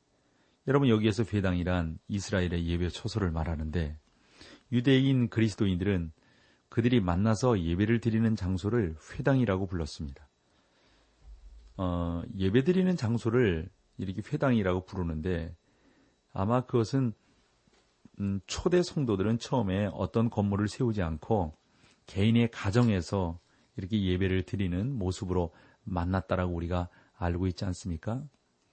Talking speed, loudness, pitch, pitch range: 290 characters per minute, -30 LUFS, 100 Hz, 90-115 Hz